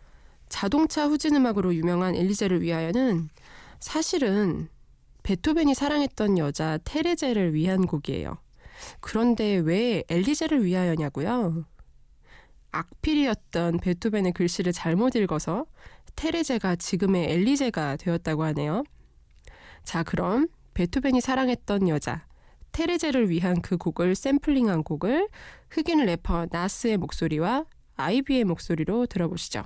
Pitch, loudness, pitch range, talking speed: 185 Hz, -26 LUFS, 170-260 Hz, 290 characters per minute